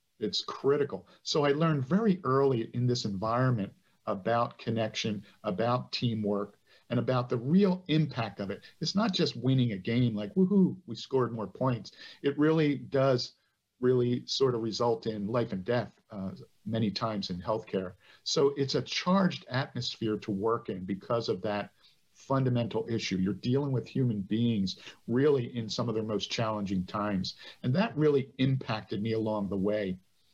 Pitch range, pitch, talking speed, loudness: 105-135 Hz, 120 Hz, 165 wpm, -30 LUFS